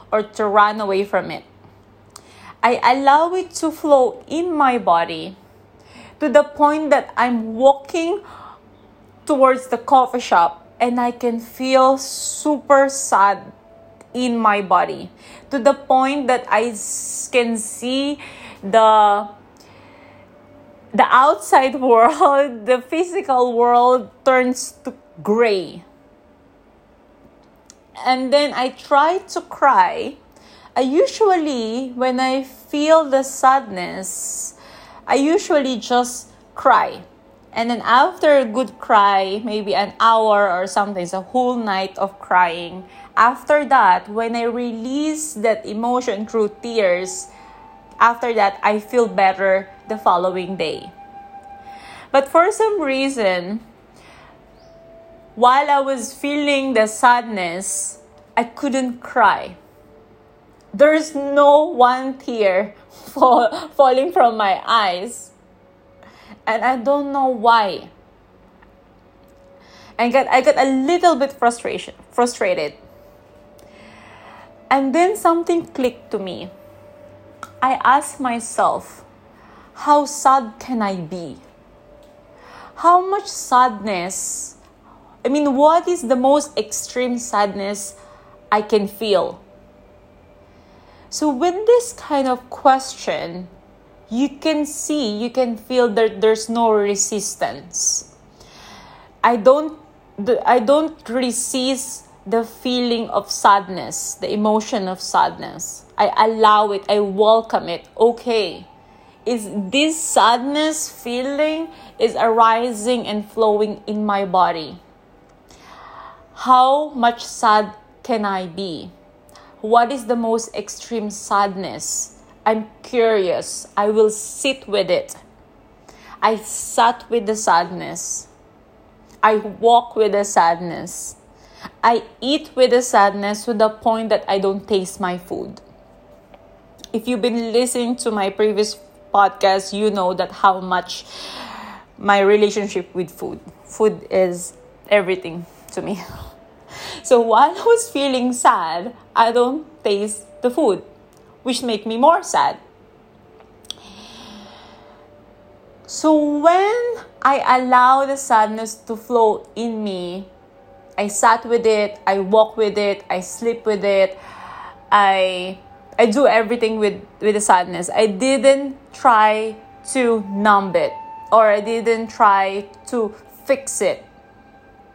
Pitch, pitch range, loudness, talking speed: 230 Hz, 205-270 Hz, -17 LUFS, 115 wpm